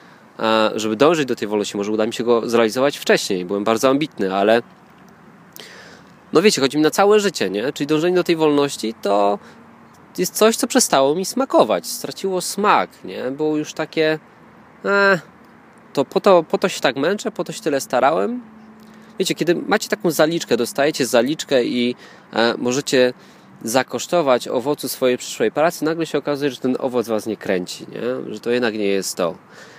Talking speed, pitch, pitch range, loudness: 175 wpm, 150 Hz, 120-190 Hz, -19 LUFS